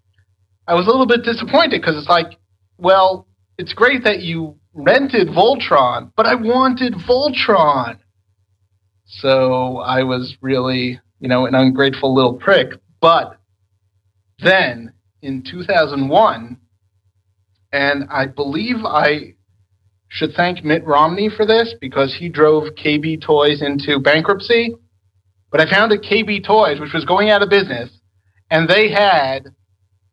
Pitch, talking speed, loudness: 140 Hz, 130 wpm, -15 LUFS